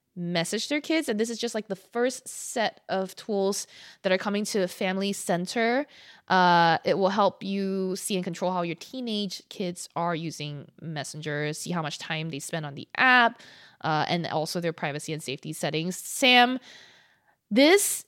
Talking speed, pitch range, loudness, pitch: 180 wpm, 165-220 Hz, -26 LUFS, 185 Hz